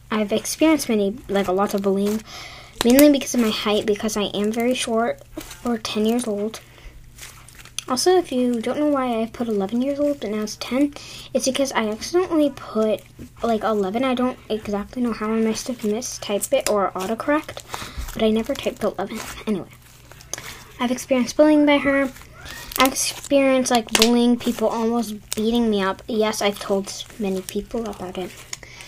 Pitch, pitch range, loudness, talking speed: 225 Hz, 210-255 Hz, -21 LUFS, 175 wpm